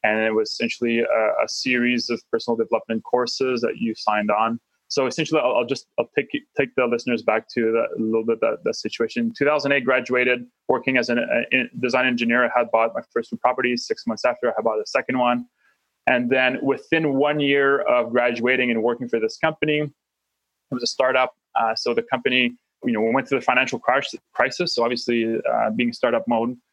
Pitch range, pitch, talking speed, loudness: 115-140 Hz, 125 Hz, 210 wpm, -22 LUFS